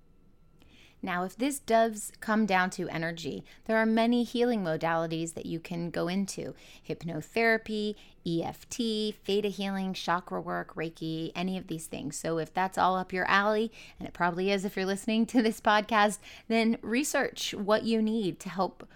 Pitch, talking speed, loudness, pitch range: 195 Hz, 170 wpm, -30 LUFS, 165-220 Hz